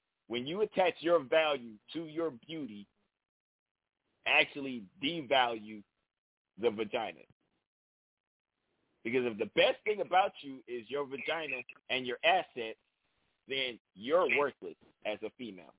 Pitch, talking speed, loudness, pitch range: 130 Hz, 120 wpm, -33 LUFS, 115-160 Hz